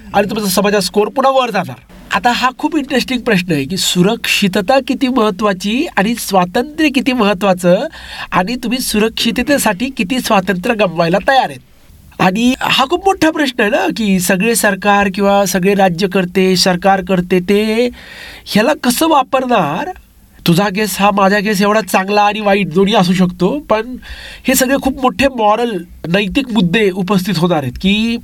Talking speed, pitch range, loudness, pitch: 155 wpm, 195-250 Hz, -13 LUFS, 210 Hz